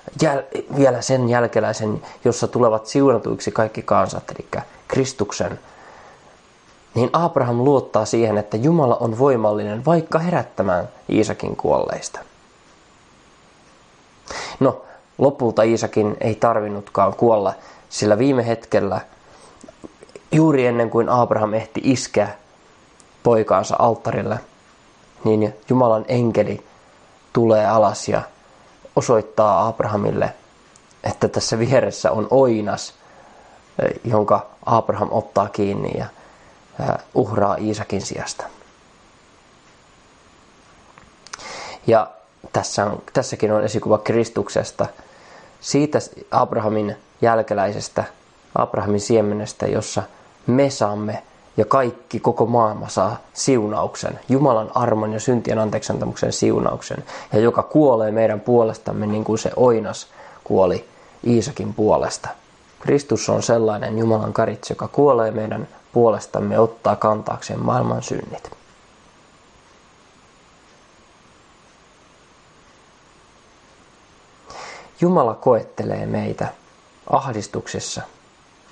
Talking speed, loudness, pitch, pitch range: 90 wpm, -20 LUFS, 110 Hz, 105-120 Hz